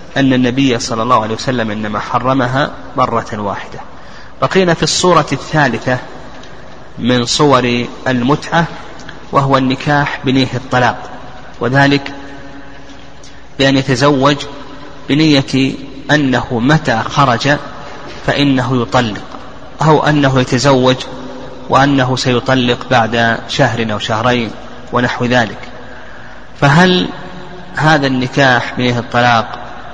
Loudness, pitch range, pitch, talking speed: -13 LUFS, 125-140 Hz, 130 Hz, 90 wpm